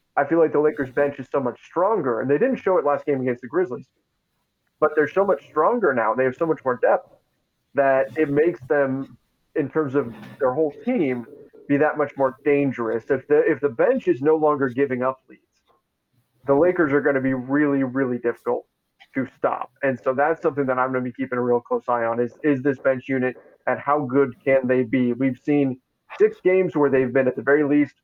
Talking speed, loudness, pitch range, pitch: 225 wpm, -22 LUFS, 130-150 Hz, 140 Hz